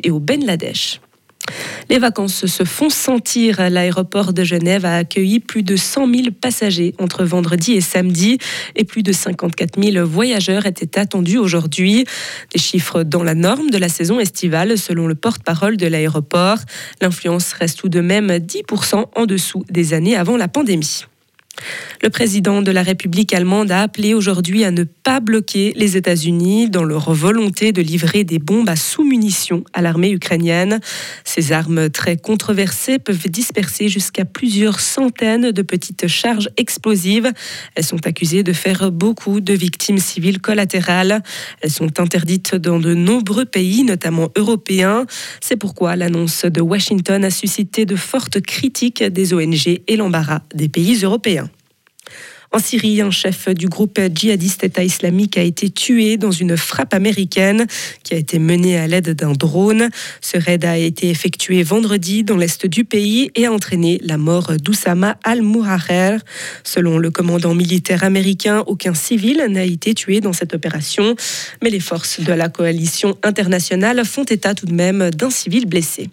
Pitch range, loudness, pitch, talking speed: 175-215 Hz, -16 LUFS, 190 Hz, 160 wpm